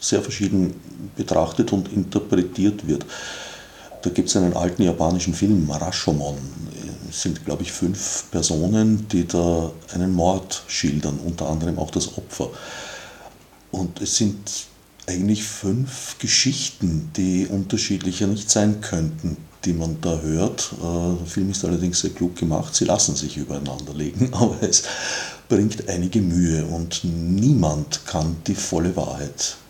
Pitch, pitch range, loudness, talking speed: 90 Hz, 85-100 Hz, -22 LUFS, 135 wpm